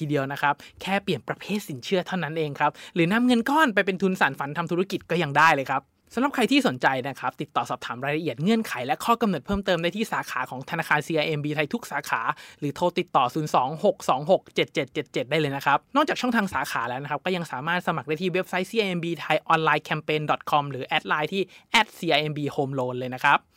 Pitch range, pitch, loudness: 145-190 Hz, 165 Hz, -25 LUFS